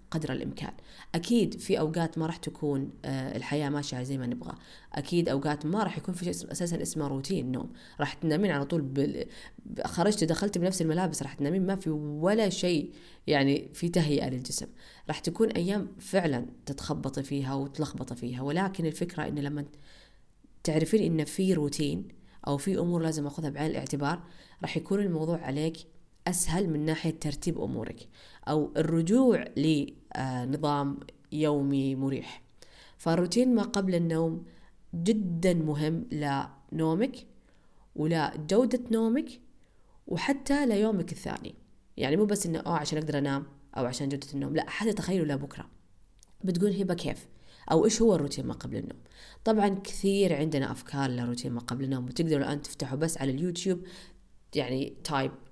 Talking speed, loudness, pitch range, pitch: 145 wpm, -30 LUFS, 145-190 Hz, 160 Hz